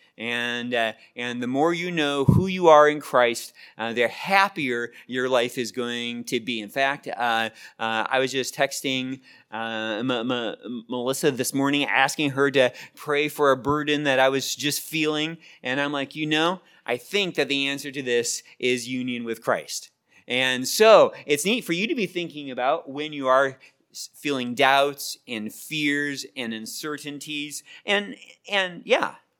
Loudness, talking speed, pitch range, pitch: -24 LUFS, 175 wpm, 125-150 Hz, 140 Hz